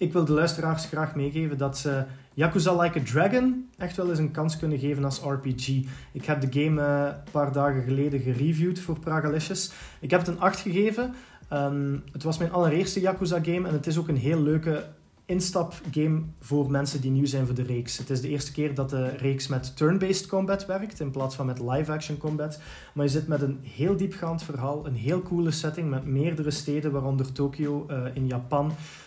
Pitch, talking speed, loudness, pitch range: 150 Hz, 200 wpm, -27 LUFS, 140-170 Hz